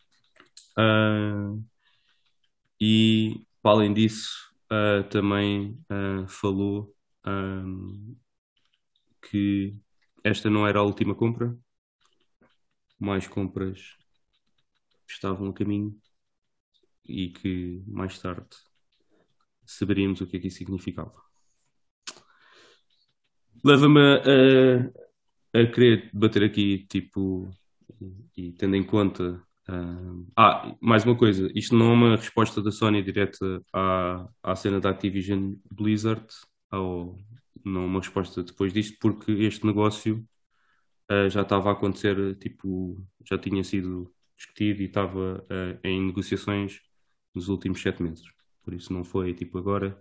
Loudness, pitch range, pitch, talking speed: -25 LUFS, 95-110 Hz, 100 Hz, 120 wpm